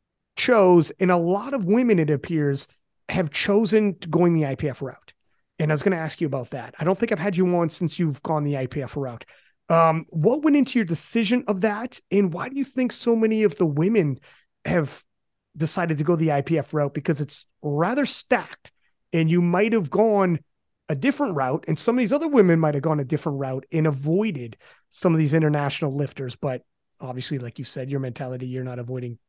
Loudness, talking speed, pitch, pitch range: -23 LUFS, 210 wpm, 160 Hz, 145-200 Hz